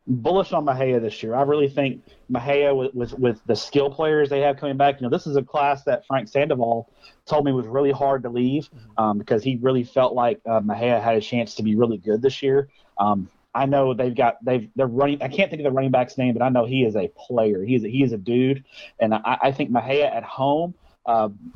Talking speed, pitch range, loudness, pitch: 250 wpm, 120-140 Hz, -22 LUFS, 130 Hz